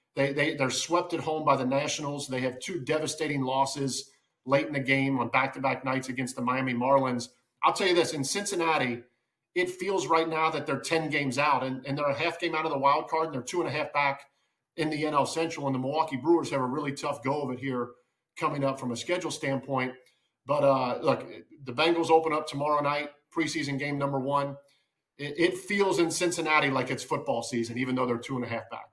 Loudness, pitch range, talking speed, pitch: -28 LUFS, 130-160 Hz, 230 wpm, 140 Hz